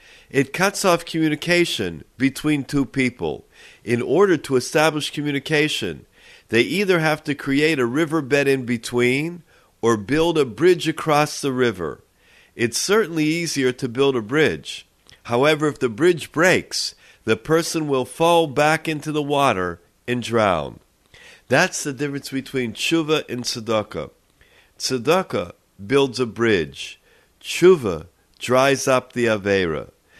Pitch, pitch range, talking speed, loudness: 140 Hz, 125-160 Hz, 130 wpm, -20 LUFS